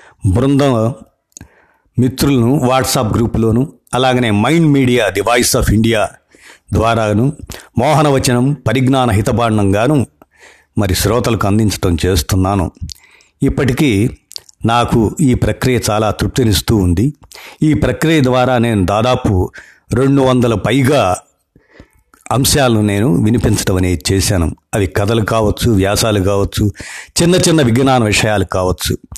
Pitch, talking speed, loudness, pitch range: 115 Hz, 100 wpm, -13 LUFS, 100-130 Hz